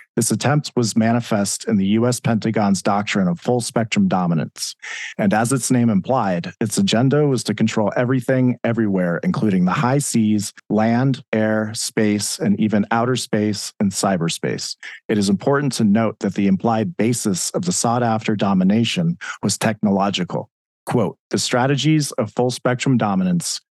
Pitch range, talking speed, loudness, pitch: 105-135 Hz, 155 wpm, -19 LUFS, 115 Hz